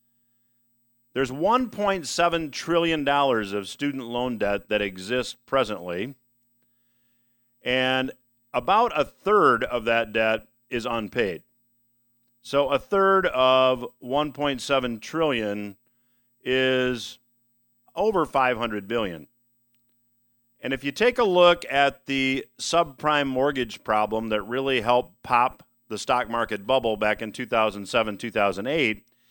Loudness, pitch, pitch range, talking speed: -24 LUFS, 120 Hz, 115-135 Hz, 105 wpm